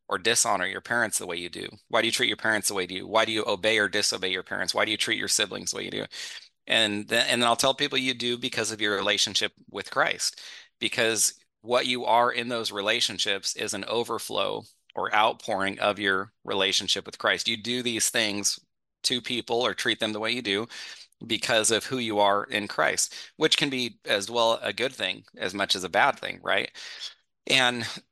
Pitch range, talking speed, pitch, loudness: 105-120 Hz, 220 wpm, 115 Hz, -25 LUFS